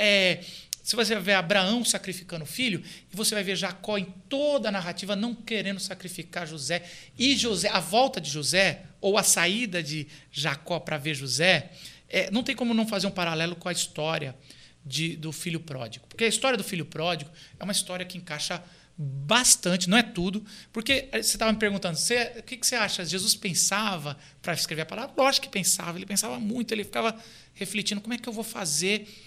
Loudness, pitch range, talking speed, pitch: -26 LUFS, 170-220 Hz, 195 wpm, 190 Hz